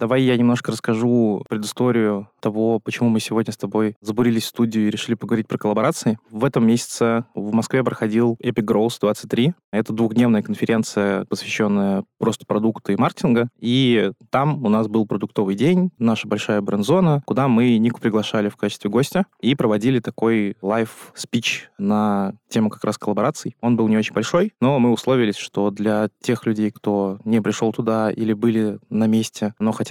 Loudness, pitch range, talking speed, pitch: -20 LUFS, 105-120 Hz, 170 wpm, 110 Hz